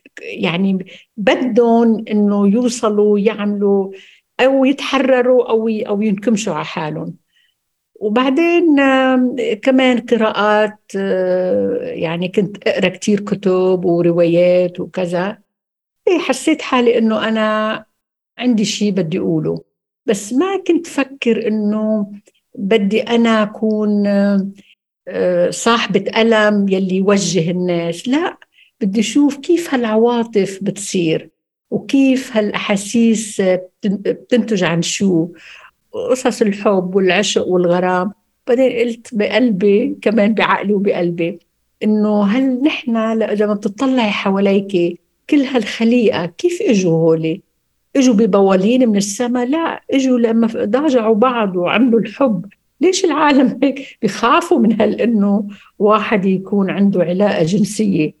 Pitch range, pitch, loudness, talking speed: 195-245 Hz, 215 Hz, -15 LUFS, 100 wpm